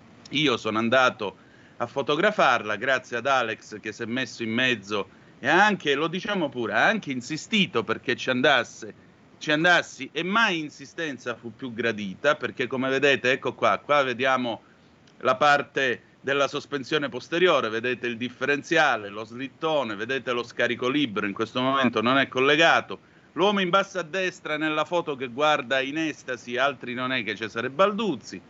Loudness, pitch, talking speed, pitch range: -24 LUFS, 130 Hz, 165 wpm, 120-155 Hz